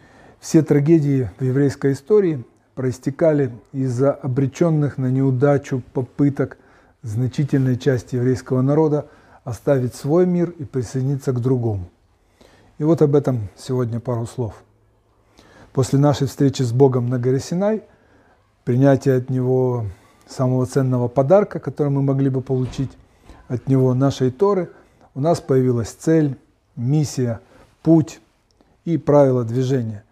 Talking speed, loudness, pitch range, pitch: 120 wpm, -19 LUFS, 125-145 Hz, 130 Hz